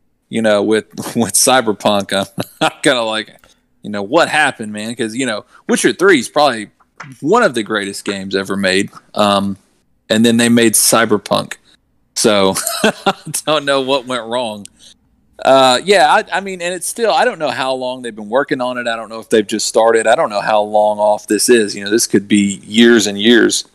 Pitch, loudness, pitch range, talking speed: 110 Hz, -14 LUFS, 105-130 Hz, 210 wpm